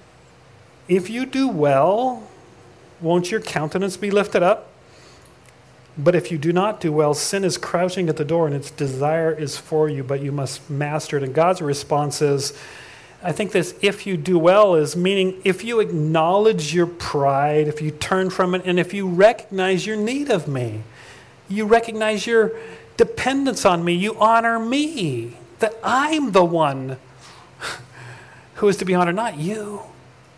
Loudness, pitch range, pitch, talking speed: -20 LUFS, 145-205 Hz, 175 Hz, 170 wpm